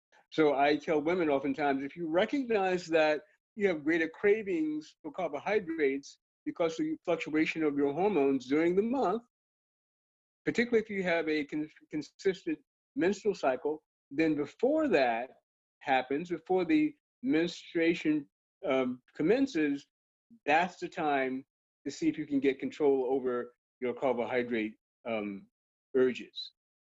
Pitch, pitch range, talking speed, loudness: 155 Hz, 140-195 Hz, 130 wpm, -31 LUFS